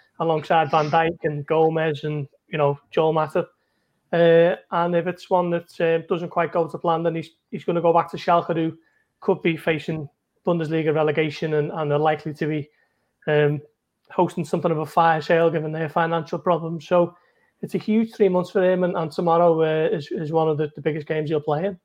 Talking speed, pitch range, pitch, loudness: 215 wpm, 155-175 Hz, 165 Hz, -22 LUFS